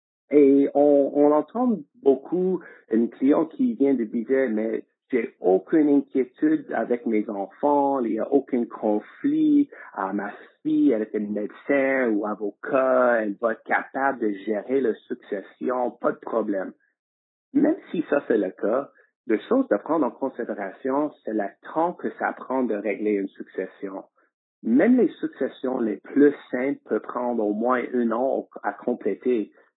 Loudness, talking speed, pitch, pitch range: -24 LUFS, 160 wpm, 135 Hz, 110-150 Hz